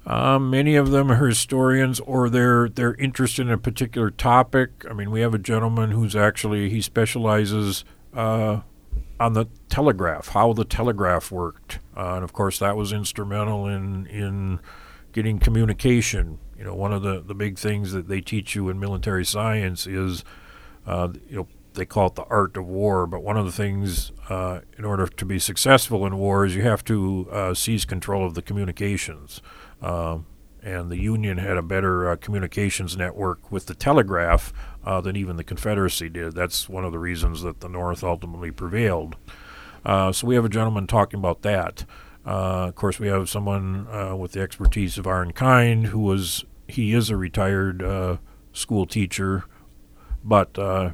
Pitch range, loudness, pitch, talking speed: 90-110 Hz, -23 LUFS, 100 Hz, 180 wpm